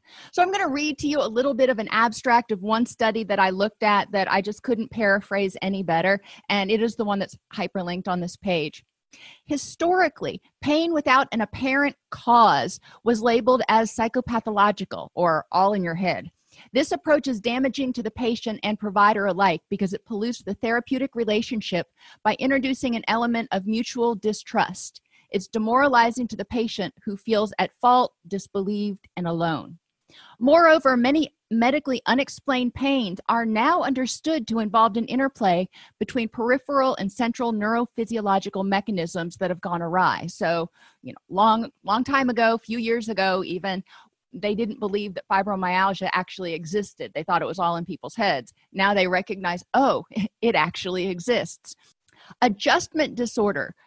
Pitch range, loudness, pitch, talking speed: 195-245 Hz, -23 LUFS, 220 Hz, 160 wpm